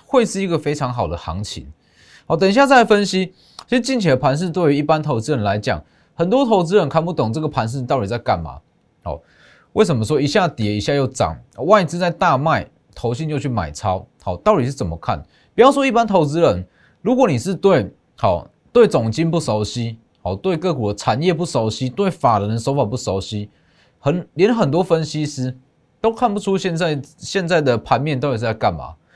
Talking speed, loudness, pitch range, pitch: 290 characters per minute, -18 LUFS, 115-185 Hz, 150 Hz